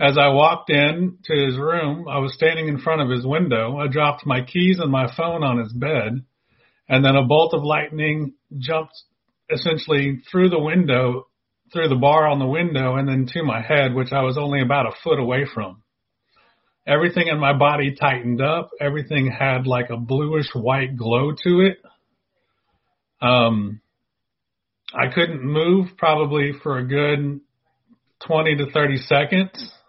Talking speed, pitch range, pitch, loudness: 165 wpm, 130-160 Hz, 145 Hz, -19 LUFS